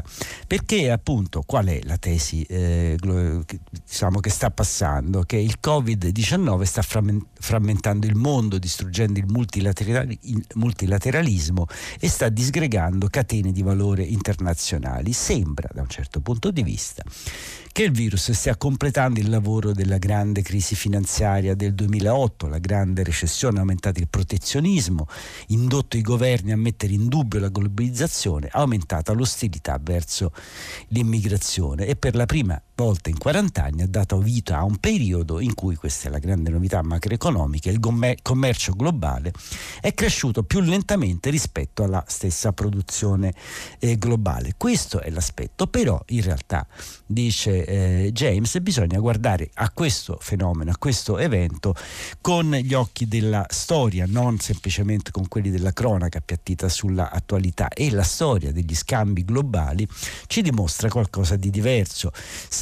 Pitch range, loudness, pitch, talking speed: 90-115 Hz, -23 LUFS, 100 Hz, 140 wpm